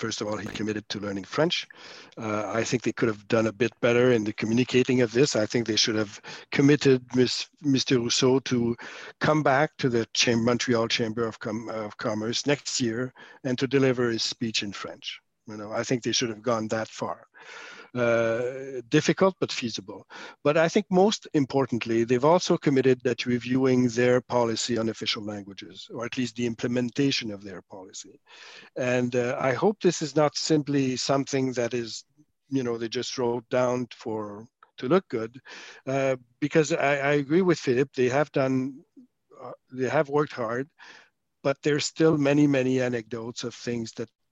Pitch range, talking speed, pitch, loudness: 115-140 Hz, 185 wpm, 125 Hz, -25 LUFS